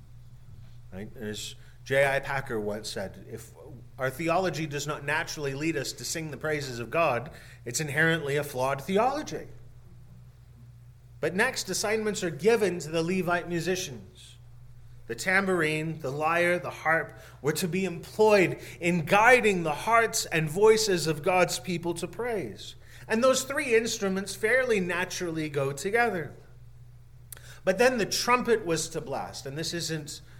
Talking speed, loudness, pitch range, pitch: 145 wpm, -27 LUFS, 125-185 Hz, 155 Hz